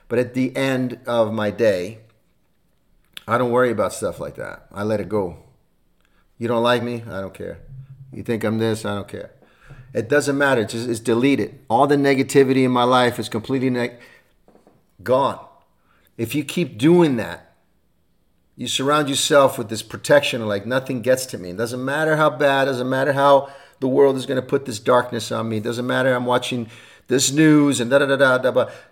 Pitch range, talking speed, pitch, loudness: 115-135 Hz, 205 wpm, 125 Hz, -19 LUFS